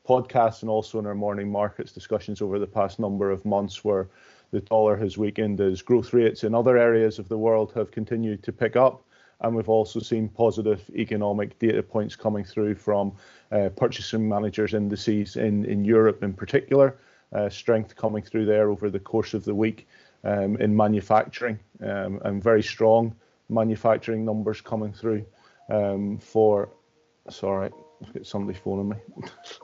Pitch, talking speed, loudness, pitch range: 110 Hz, 170 wpm, -25 LUFS, 105-110 Hz